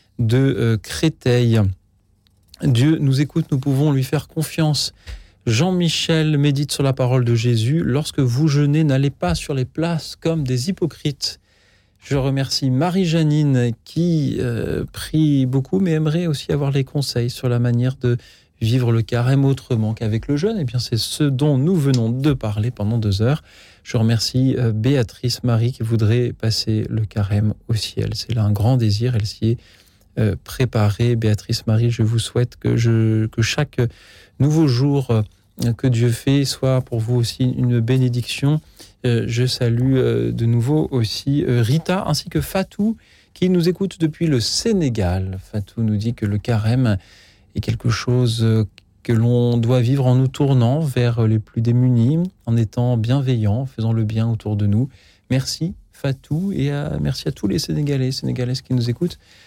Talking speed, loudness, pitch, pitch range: 165 wpm, -19 LUFS, 125 Hz, 110-140 Hz